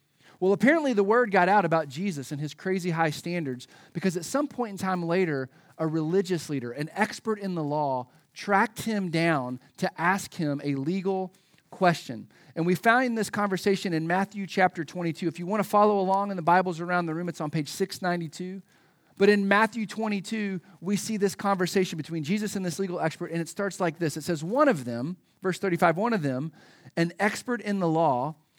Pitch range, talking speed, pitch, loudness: 160-200 Hz, 200 wpm, 180 Hz, -27 LUFS